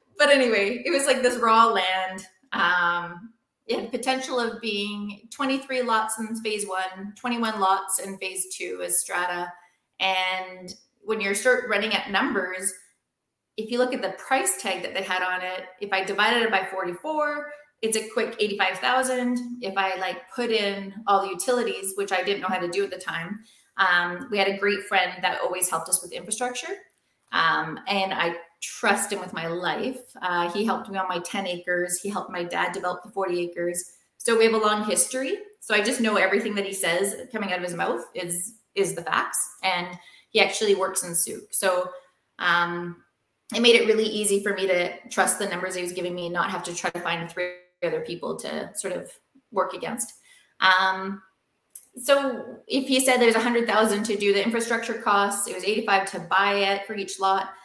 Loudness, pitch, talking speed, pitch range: -24 LUFS, 195 Hz, 200 wpm, 185-230 Hz